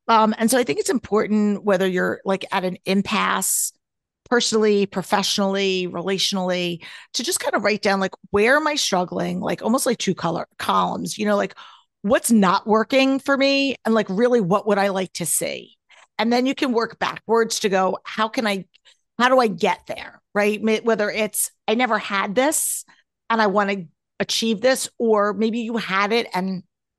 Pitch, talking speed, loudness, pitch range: 210 Hz, 190 wpm, -21 LUFS, 195-235 Hz